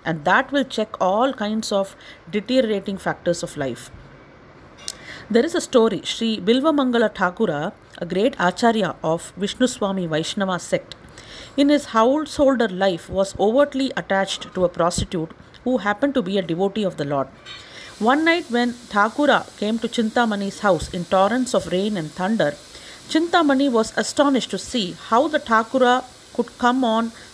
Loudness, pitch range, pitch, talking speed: -21 LUFS, 190-255 Hz, 220 Hz, 150 wpm